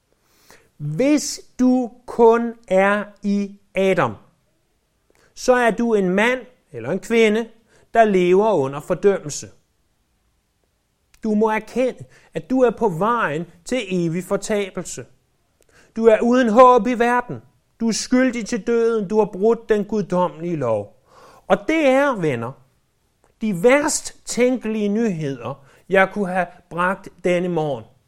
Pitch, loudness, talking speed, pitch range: 210 Hz, -19 LUFS, 130 wpm, 180-235 Hz